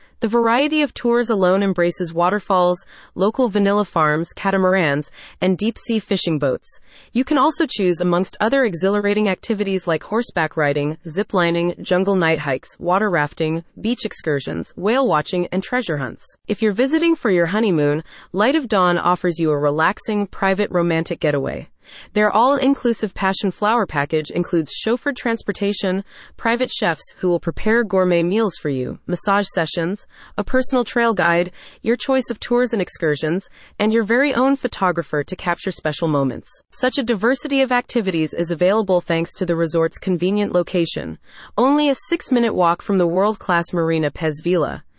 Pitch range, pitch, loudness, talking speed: 170-230 Hz, 190 Hz, -19 LUFS, 155 wpm